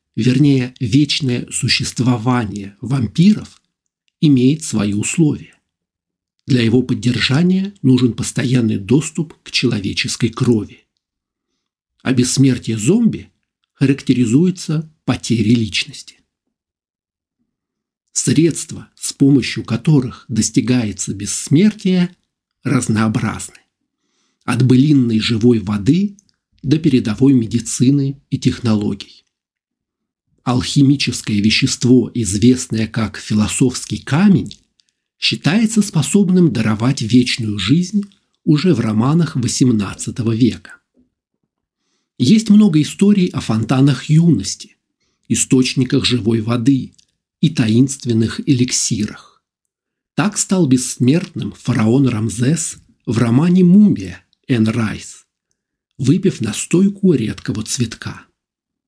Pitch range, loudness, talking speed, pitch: 115-145 Hz, -15 LUFS, 80 wpm, 125 Hz